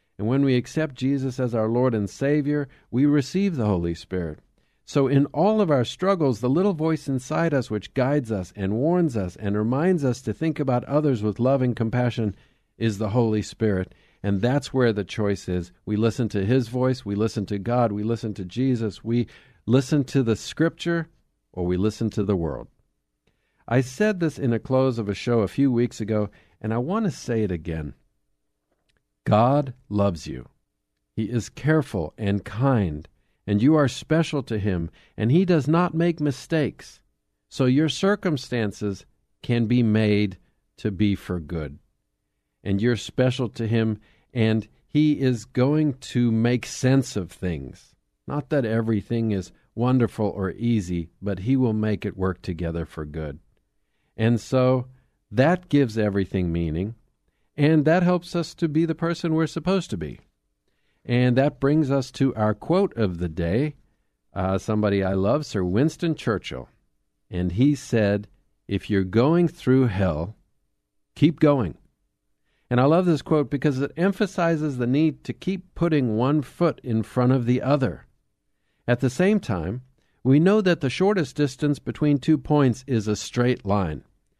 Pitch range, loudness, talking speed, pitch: 105-145 Hz, -23 LUFS, 170 wpm, 120 Hz